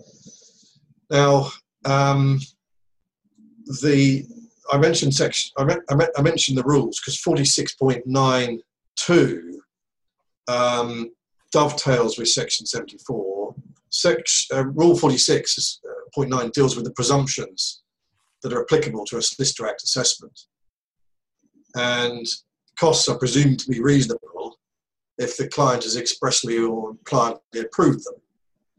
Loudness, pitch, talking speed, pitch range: -20 LUFS, 135 Hz, 110 wpm, 120-145 Hz